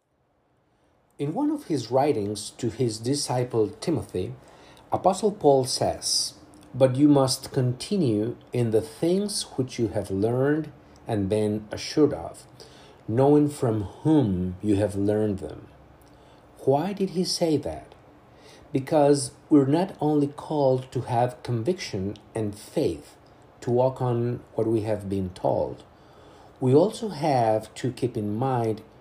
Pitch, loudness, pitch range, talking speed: 130 Hz, -25 LUFS, 110-145 Hz, 130 wpm